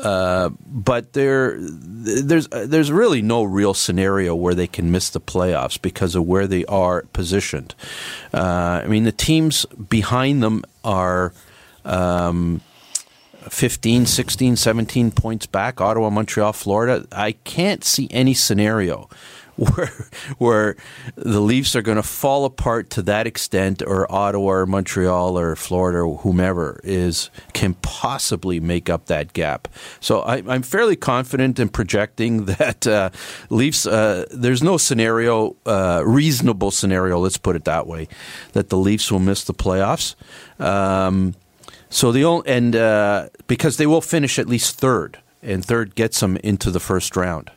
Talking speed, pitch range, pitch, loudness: 150 wpm, 95-120 Hz, 105 Hz, -19 LUFS